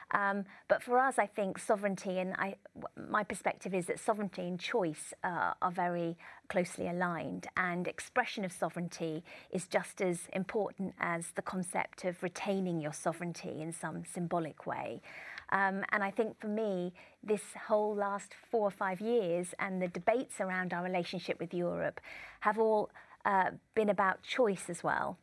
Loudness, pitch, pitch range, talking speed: -35 LUFS, 185 Hz, 175-210 Hz, 165 wpm